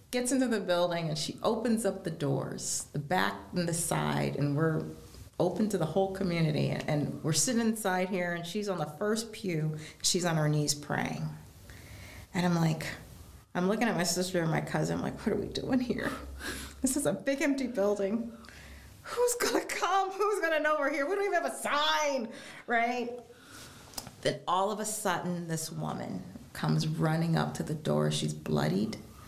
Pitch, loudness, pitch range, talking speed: 180 Hz, -31 LUFS, 150-230 Hz, 190 wpm